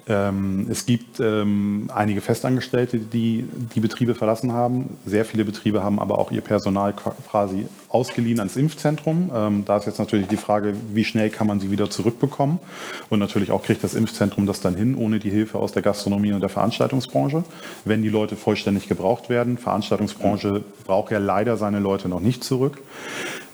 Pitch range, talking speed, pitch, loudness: 100-120 Hz, 170 wpm, 110 Hz, -23 LUFS